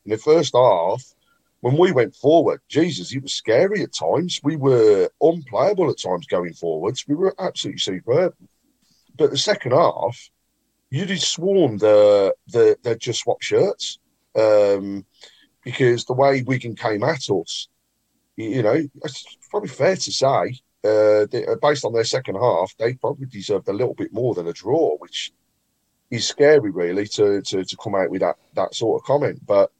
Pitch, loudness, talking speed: 155 Hz, -20 LUFS, 175 wpm